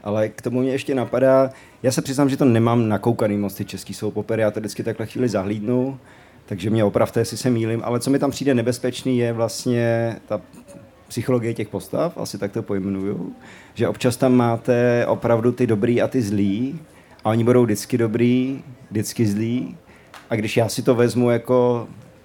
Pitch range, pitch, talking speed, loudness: 110-125 Hz, 120 Hz, 190 wpm, -21 LUFS